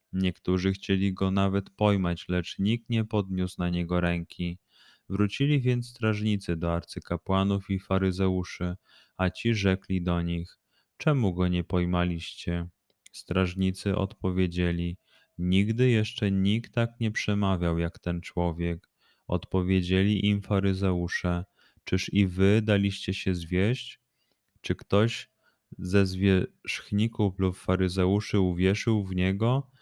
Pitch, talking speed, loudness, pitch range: 95 Hz, 115 wpm, -28 LUFS, 90-105 Hz